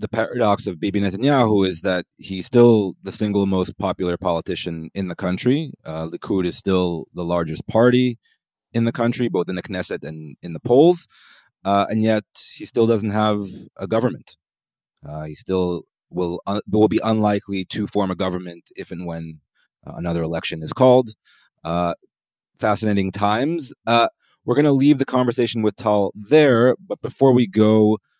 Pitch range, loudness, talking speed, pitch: 90-115 Hz, -20 LUFS, 170 wpm, 100 Hz